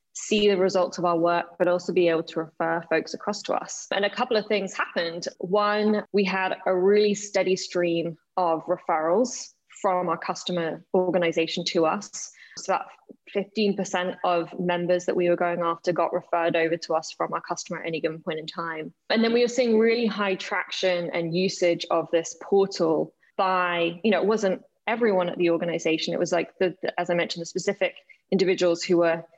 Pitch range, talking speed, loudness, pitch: 170-195 Hz, 195 wpm, -25 LUFS, 180 Hz